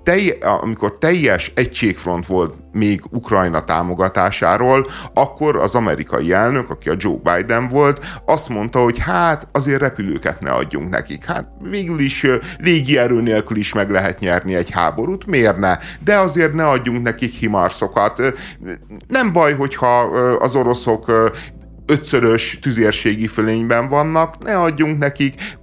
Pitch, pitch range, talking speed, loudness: 120 Hz, 105-150 Hz, 130 wpm, -16 LUFS